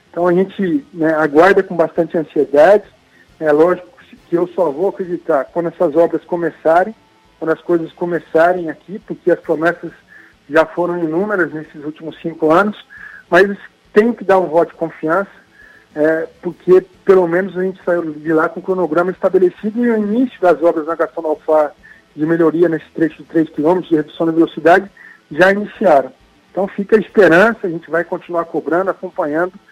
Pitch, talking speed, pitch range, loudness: 175 Hz, 170 wpm, 160-185 Hz, -15 LUFS